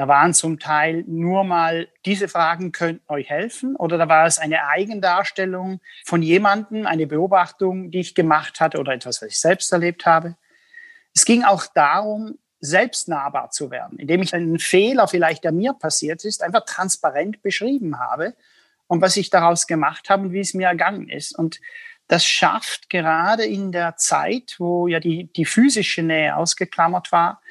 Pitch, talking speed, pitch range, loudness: 180 Hz, 170 wpm, 165-200 Hz, -19 LUFS